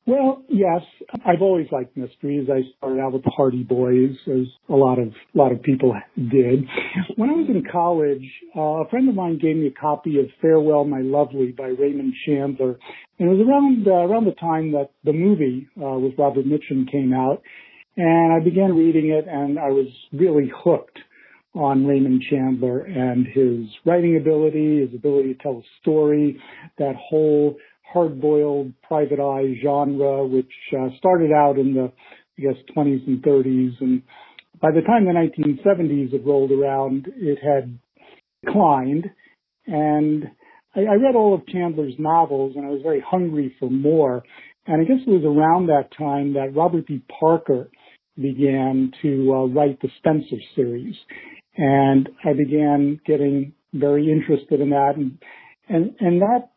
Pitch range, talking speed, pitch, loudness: 135-165 Hz, 165 wpm, 145 Hz, -20 LUFS